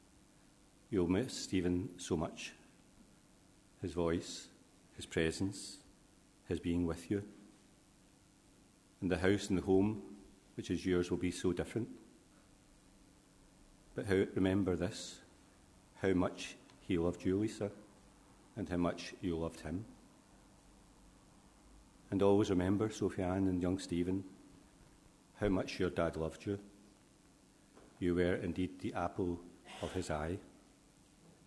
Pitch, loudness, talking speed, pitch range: 95 Hz, -37 LUFS, 120 wpm, 85-100 Hz